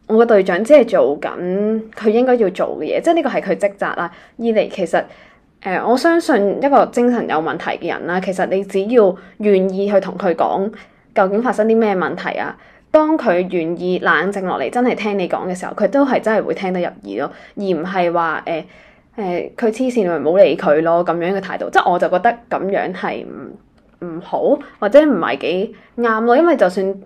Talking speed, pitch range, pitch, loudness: 295 characters per minute, 185-235 Hz, 200 Hz, -16 LUFS